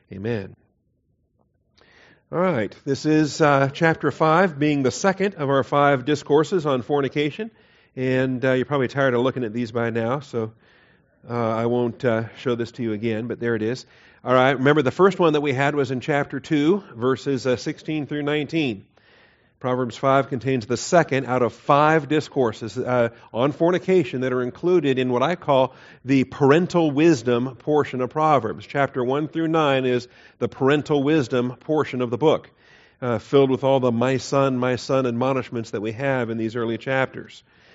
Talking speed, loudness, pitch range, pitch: 180 wpm, -22 LUFS, 120-150 Hz, 130 Hz